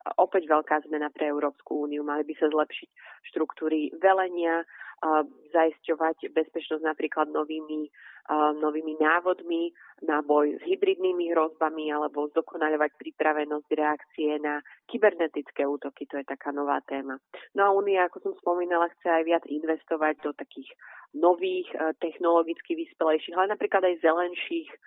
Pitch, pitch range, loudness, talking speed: 160 Hz, 150-180 Hz, -27 LUFS, 130 wpm